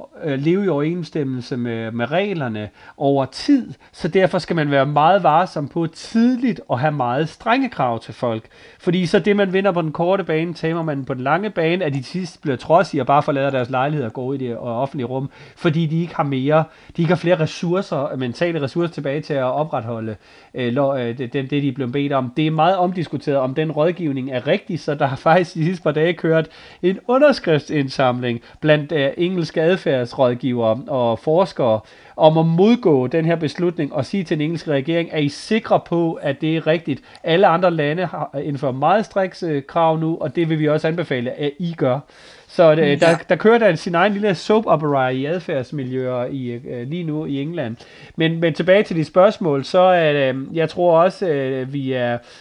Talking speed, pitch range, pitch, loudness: 205 wpm, 135-175 Hz, 155 Hz, -19 LUFS